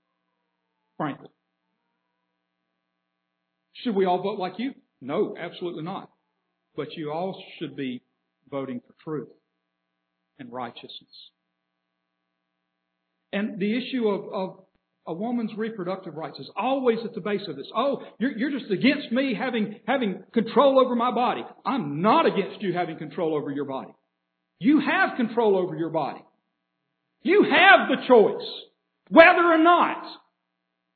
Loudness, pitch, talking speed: -23 LUFS, 175 Hz, 135 wpm